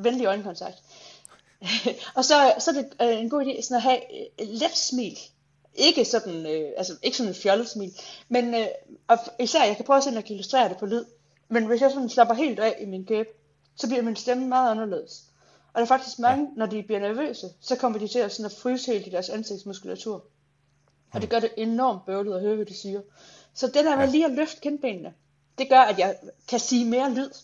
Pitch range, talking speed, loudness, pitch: 200-260 Hz, 215 wpm, -24 LUFS, 230 Hz